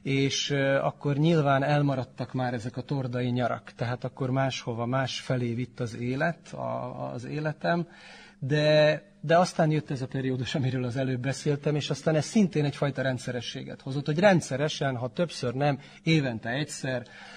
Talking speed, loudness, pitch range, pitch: 155 wpm, -28 LUFS, 130-155 Hz, 140 Hz